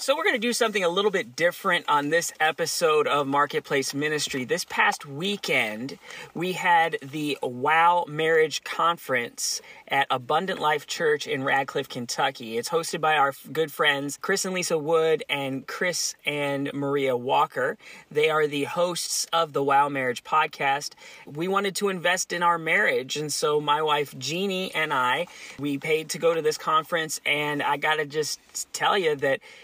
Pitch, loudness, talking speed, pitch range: 155 Hz, -24 LUFS, 170 wpm, 145-185 Hz